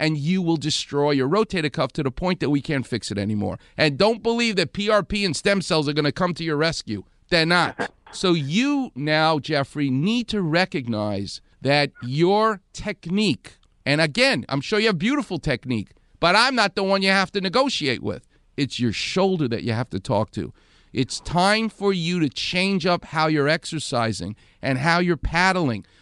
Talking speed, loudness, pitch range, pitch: 190 wpm, -22 LUFS, 130-190 Hz, 155 Hz